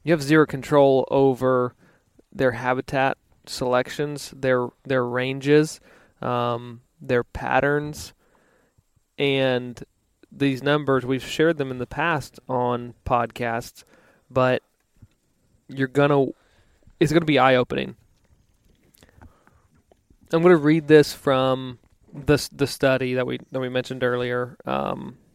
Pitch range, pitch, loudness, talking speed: 125-145 Hz, 130 Hz, -22 LUFS, 110 wpm